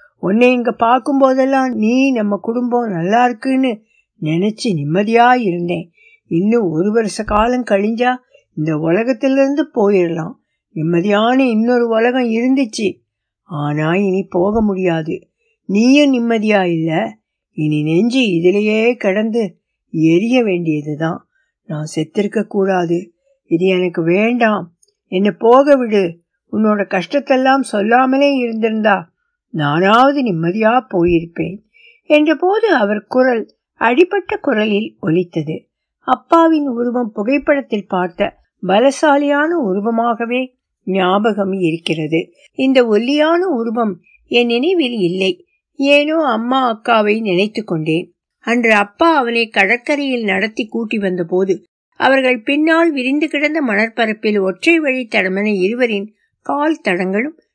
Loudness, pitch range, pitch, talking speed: -15 LUFS, 185-260 Hz, 225 Hz, 100 wpm